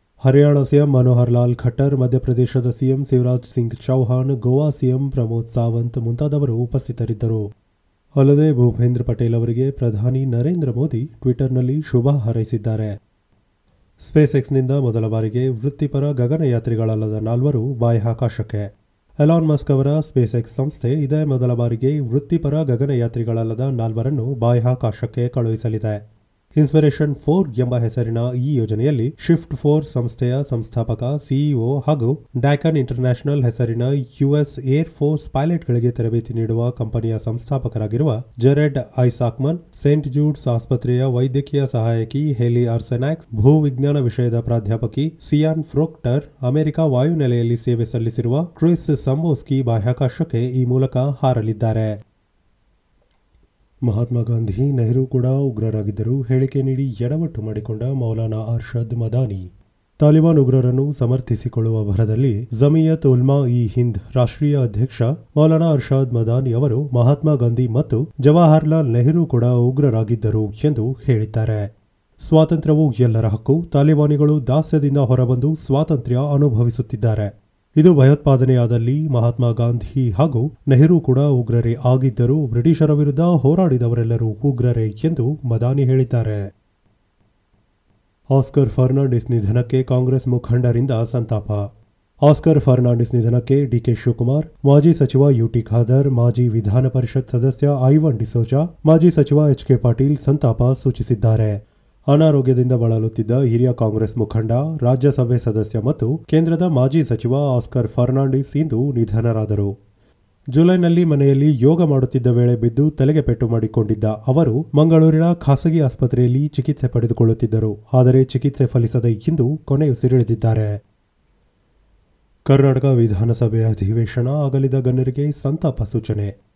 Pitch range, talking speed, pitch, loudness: 115-140 Hz, 105 wpm, 125 Hz, -17 LUFS